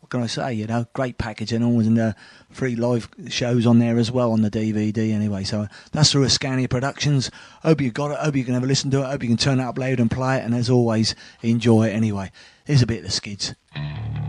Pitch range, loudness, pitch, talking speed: 110-135 Hz, -21 LUFS, 120 Hz, 260 wpm